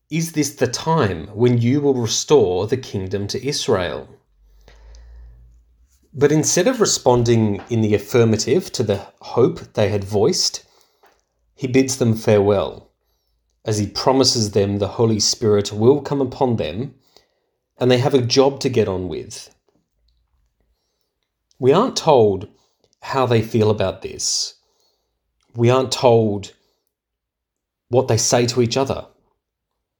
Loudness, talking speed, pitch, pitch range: -18 LUFS, 130 wpm, 115 Hz, 100-135 Hz